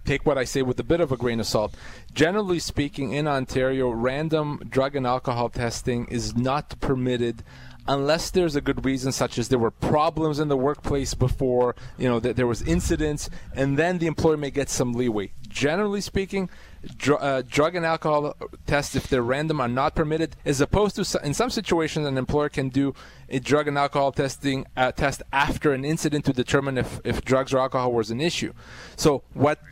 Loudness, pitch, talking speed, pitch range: -24 LUFS, 140 Hz, 200 wpm, 125-150 Hz